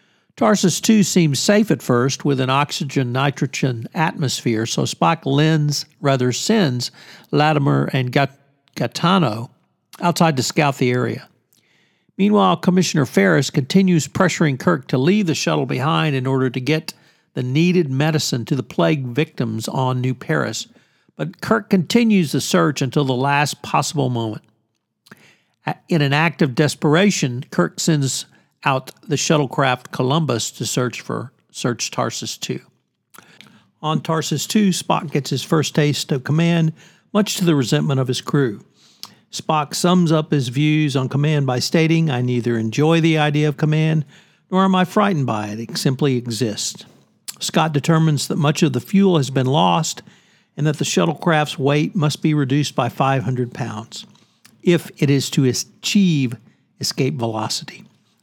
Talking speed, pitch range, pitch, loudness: 155 wpm, 130-170 Hz, 150 Hz, -18 LUFS